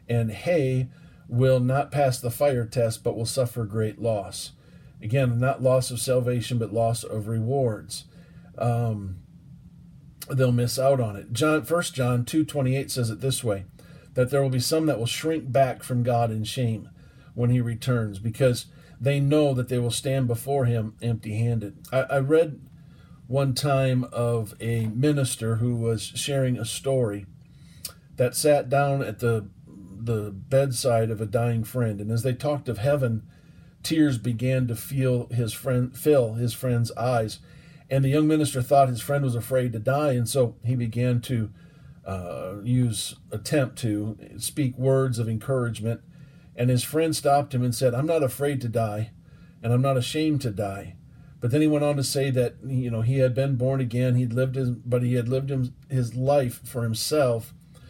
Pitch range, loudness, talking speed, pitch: 115-140 Hz, -25 LUFS, 180 wpm, 125 Hz